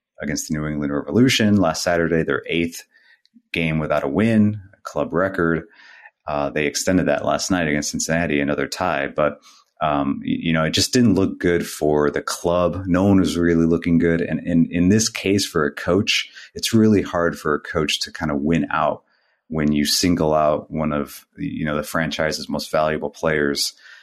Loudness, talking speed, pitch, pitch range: -20 LUFS, 190 wpm, 85 Hz, 75-90 Hz